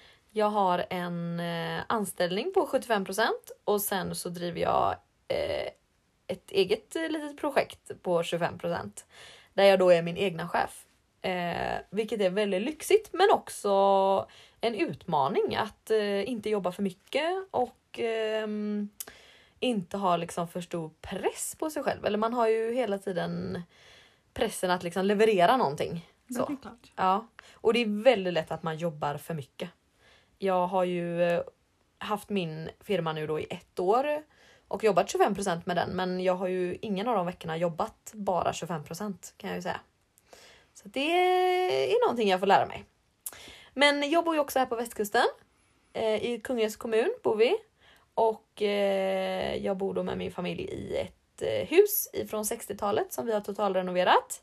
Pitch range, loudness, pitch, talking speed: 180-265 Hz, -29 LUFS, 205 Hz, 160 wpm